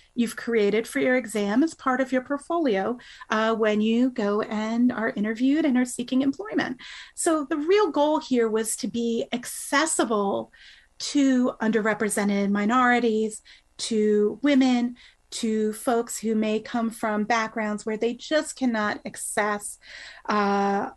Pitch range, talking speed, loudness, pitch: 215-260 Hz, 135 wpm, -24 LUFS, 230 Hz